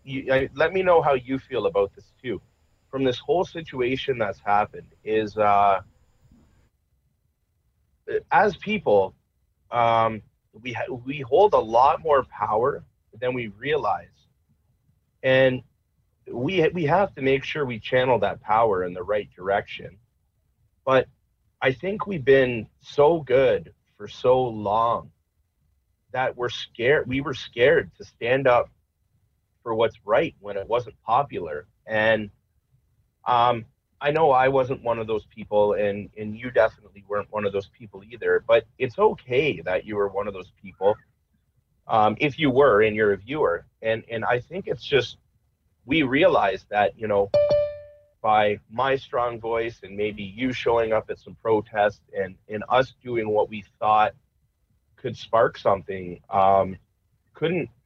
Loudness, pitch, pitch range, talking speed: -23 LUFS, 115 Hz, 105-135 Hz, 155 wpm